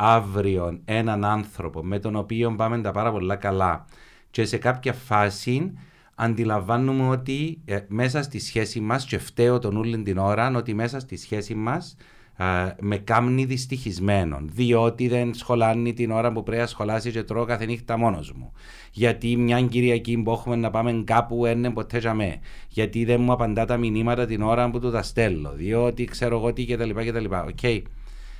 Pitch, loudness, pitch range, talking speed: 115 Hz, -24 LUFS, 105-120 Hz, 170 wpm